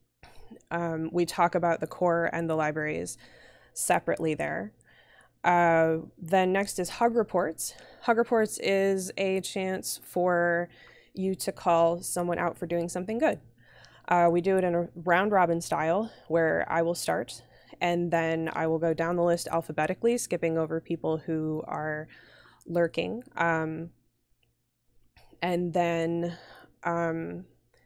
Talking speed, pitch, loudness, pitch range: 140 wpm, 170 Hz, -28 LUFS, 165-180 Hz